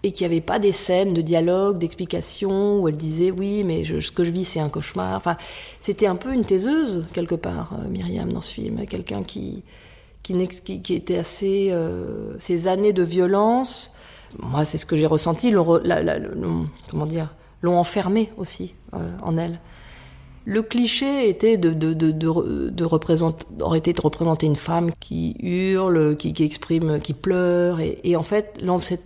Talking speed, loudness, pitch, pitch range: 180 wpm, -22 LUFS, 175 Hz, 160-195 Hz